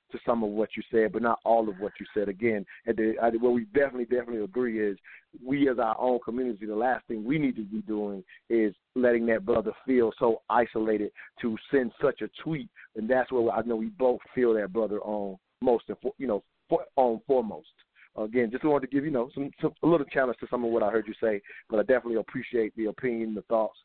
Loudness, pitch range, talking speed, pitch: -28 LUFS, 110-125 Hz, 225 wpm, 115 Hz